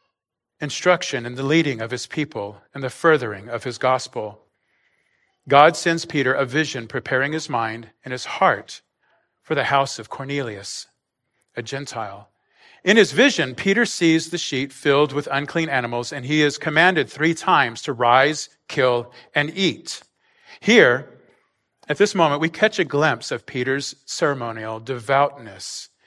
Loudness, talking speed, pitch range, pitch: -20 LUFS, 150 wpm, 125-155 Hz, 140 Hz